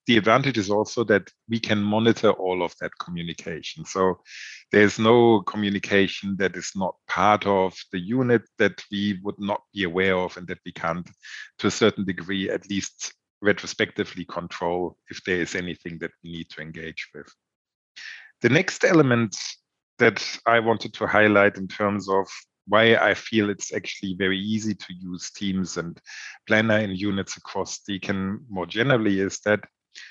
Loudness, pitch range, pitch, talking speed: -23 LUFS, 90-105 Hz, 100 Hz, 165 wpm